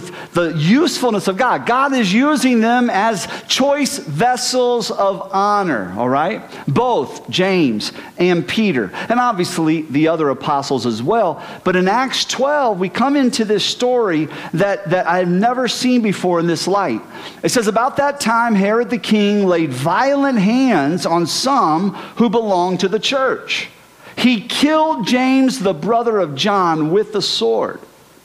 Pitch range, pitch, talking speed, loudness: 180-245 Hz, 210 Hz, 155 wpm, -16 LUFS